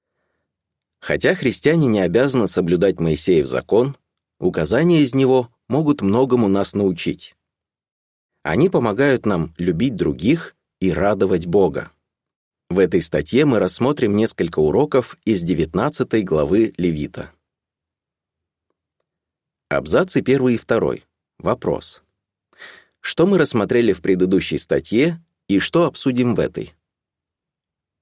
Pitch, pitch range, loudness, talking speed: 120 Hz, 95-135 Hz, -18 LUFS, 105 wpm